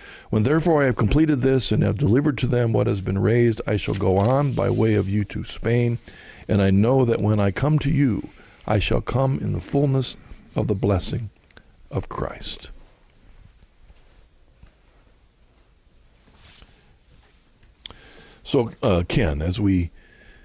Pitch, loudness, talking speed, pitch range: 110 Hz, -22 LUFS, 145 wpm, 100-130 Hz